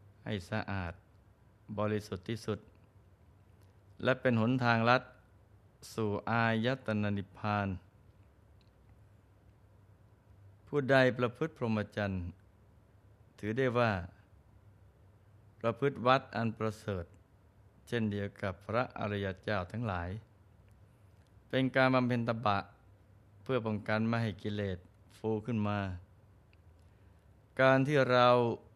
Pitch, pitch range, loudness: 105 Hz, 100-115 Hz, -33 LUFS